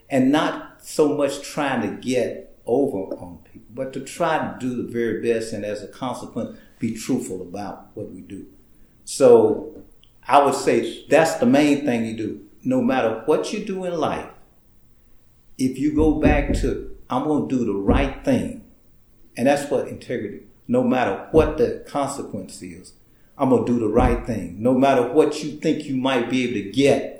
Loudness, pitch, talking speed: -21 LUFS, 140 Hz, 185 wpm